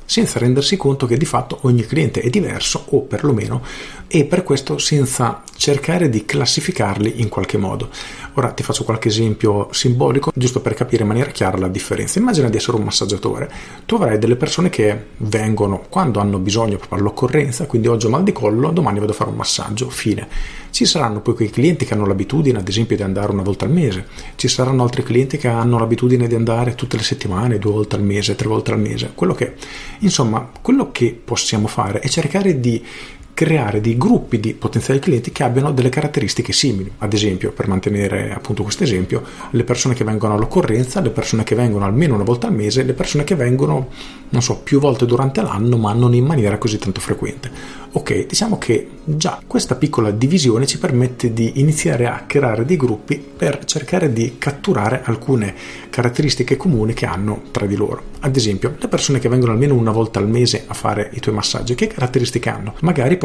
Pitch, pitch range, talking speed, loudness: 120 Hz, 105-140 Hz, 195 wpm, -17 LUFS